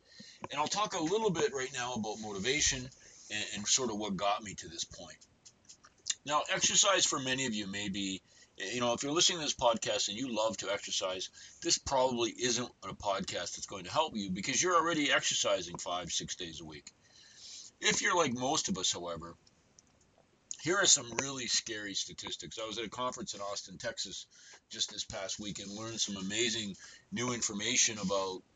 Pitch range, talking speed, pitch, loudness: 100-135 Hz, 195 wpm, 120 Hz, -32 LUFS